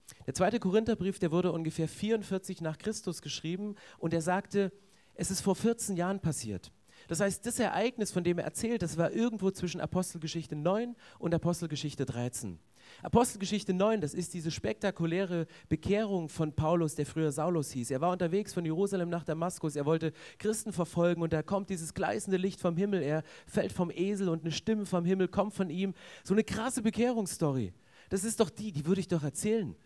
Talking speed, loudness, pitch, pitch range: 185 wpm, -33 LUFS, 180 Hz, 160-200 Hz